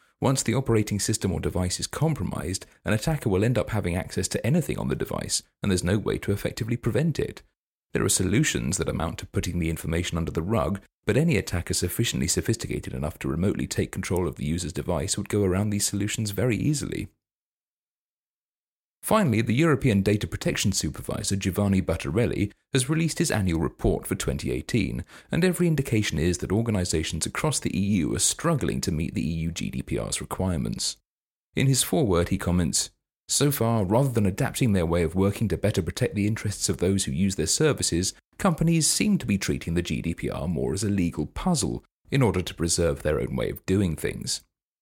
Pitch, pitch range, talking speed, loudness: 100 Hz, 85-115 Hz, 185 wpm, -26 LUFS